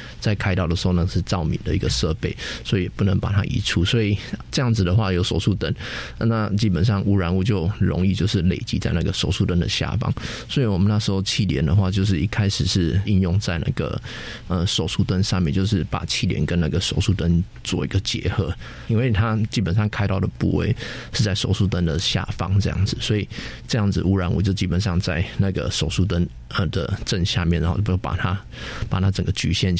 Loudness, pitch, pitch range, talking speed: -22 LUFS, 95 Hz, 90-110 Hz, 320 characters per minute